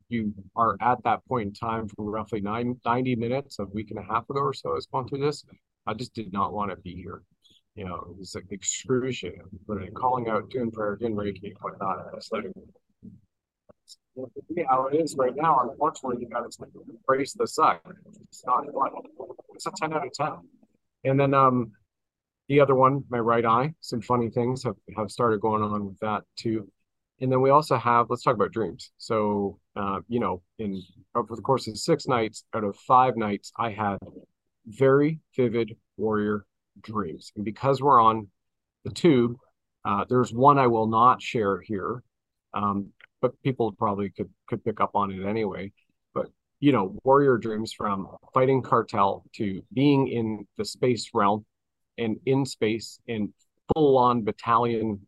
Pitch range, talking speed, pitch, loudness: 105-130 Hz, 180 wpm, 115 Hz, -26 LUFS